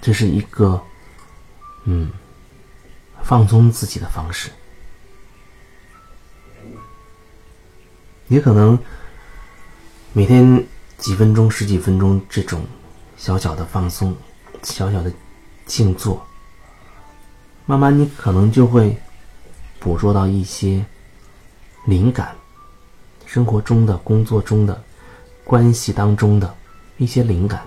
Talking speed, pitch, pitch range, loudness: 145 characters per minute, 100 Hz, 90-110 Hz, -16 LUFS